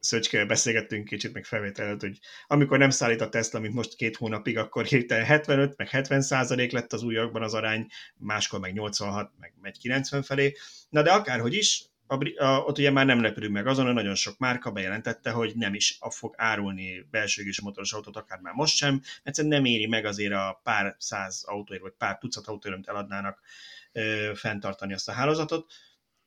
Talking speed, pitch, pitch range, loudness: 185 wpm, 115 Hz, 105-135 Hz, -27 LUFS